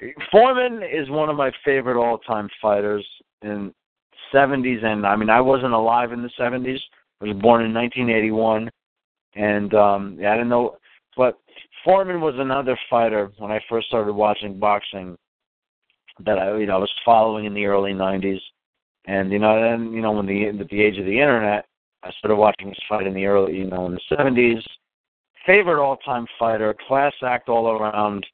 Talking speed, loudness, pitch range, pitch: 180 wpm, -20 LUFS, 105-120 Hz, 110 Hz